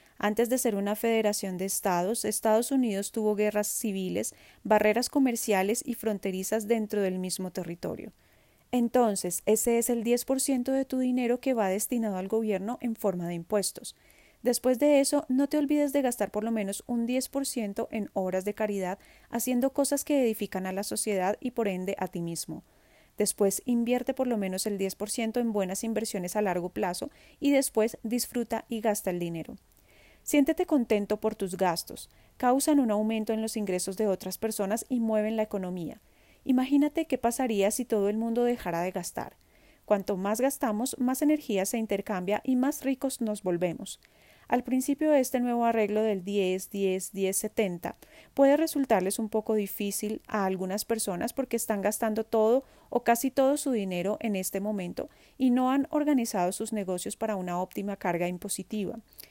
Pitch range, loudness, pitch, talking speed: 195-250 Hz, -29 LUFS, 220 Hz, 170 wpm